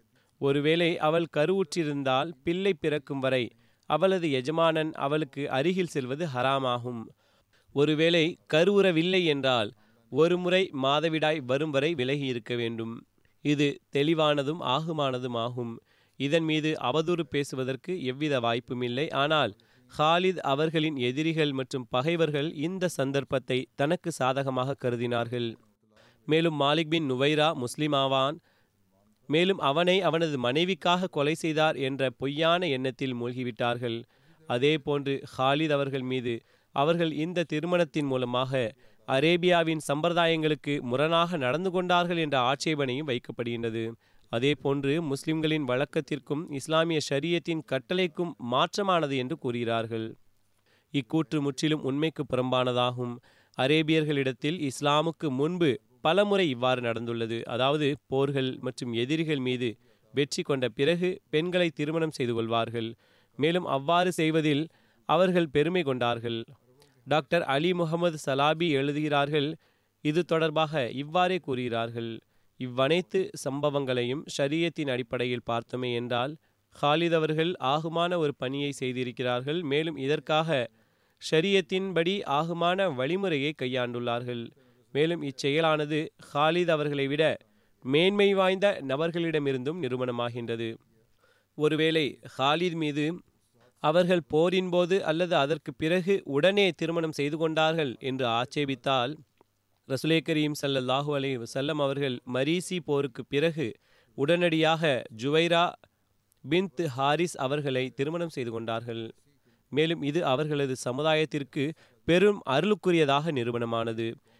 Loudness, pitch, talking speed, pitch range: -28 LUFS, 145 Hz, 95 wpm, 125-160 Hz